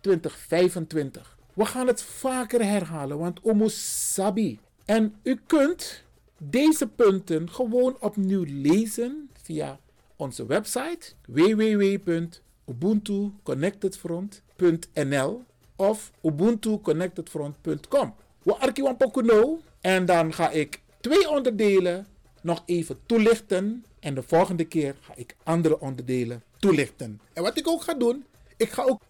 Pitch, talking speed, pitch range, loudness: 195 Hz, 105 wpm, 160-235 Hz, -25 LUFS